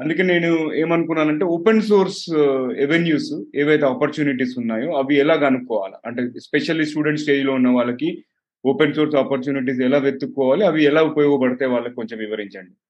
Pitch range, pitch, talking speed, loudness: 130-155 Hz, 140 Hz, 140 wpm, -19 LUFS